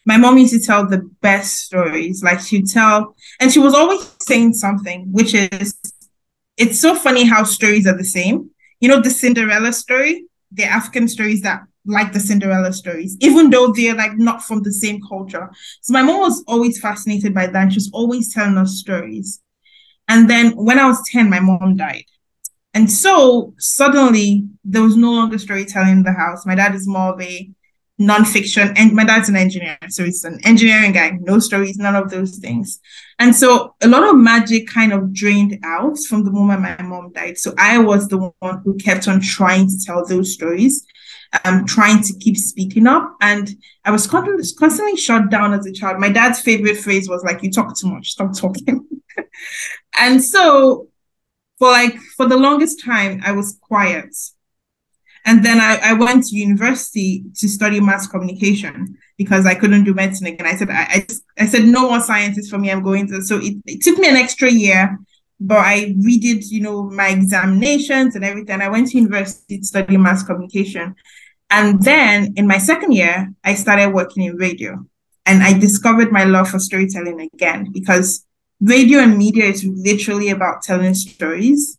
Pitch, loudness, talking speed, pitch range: 205 Hz, -13 LUFS, 190 wpm, 195-235 Hz